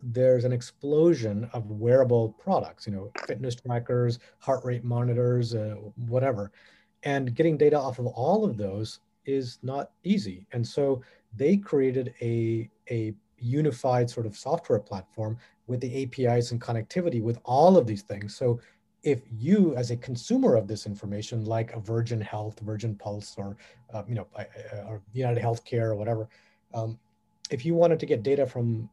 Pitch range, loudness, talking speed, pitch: 110-130 Hz, -27 LUFS, 165 wpm, 120 Hz